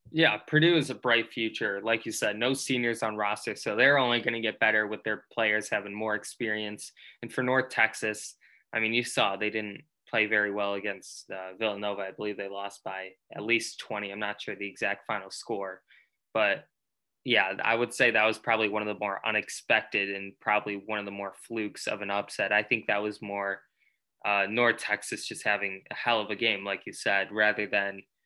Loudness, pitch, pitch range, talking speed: -28 LUFS, 105 Hz, 100-115 Hz, 210 wpm